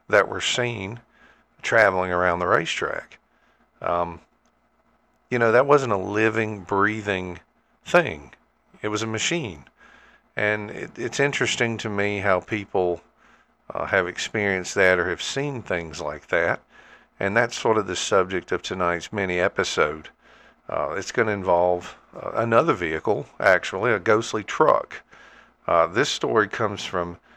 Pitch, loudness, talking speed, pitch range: 100 Hz, -23 LUFS, 145 wpm, 90-110 Hz